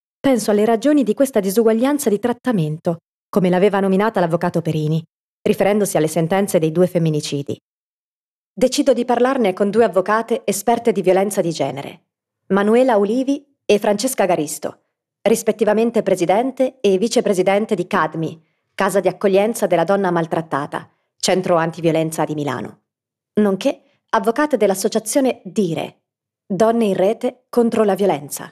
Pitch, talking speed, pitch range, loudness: 200 Hz, 130 wpm, 170-230 Hz, -18 LUFS